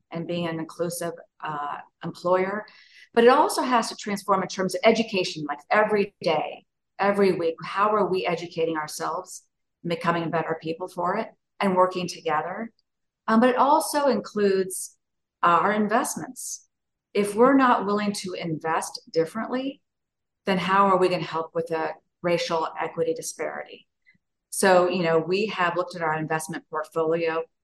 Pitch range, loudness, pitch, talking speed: 165-205 Hz, -24 LUFS, 180 Hz, 150 wpm